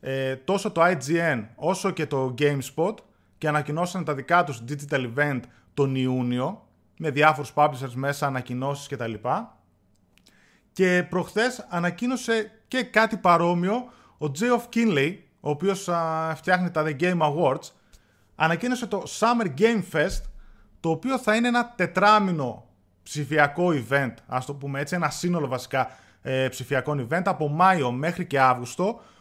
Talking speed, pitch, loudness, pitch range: 140 wpm, 155 Hz, -25 LUFS, 135-185 Hz